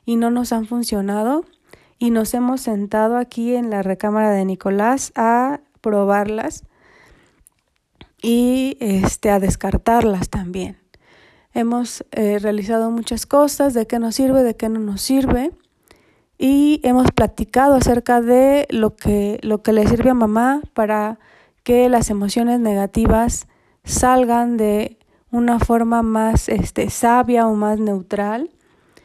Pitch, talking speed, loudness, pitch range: 230 Hz, 130 wpm, -18 LUFS, 215-245 Hz